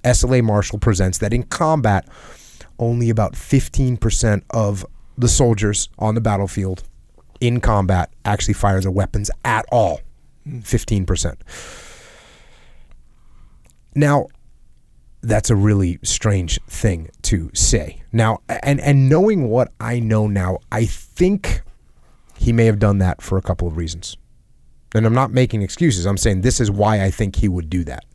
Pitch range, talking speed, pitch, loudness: 95-120 Hz, 145 wpm, 105 Hz, -18 LUFS